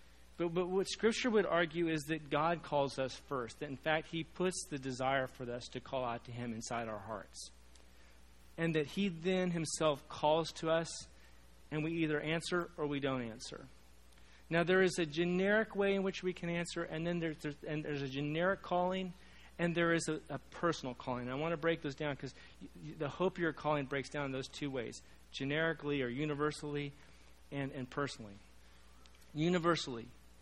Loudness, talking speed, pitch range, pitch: -37 LUFS, 195 wpm, 120-170 Hz, 150 Hz